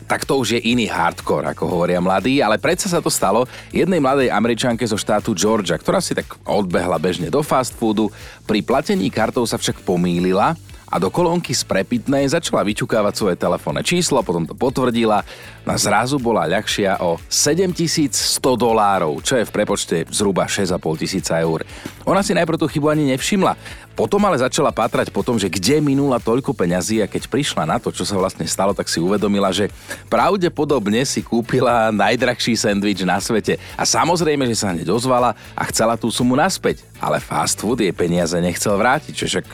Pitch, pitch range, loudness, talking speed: 115 Hz, 100-145 Hz, -18 LUFS, 180 wpm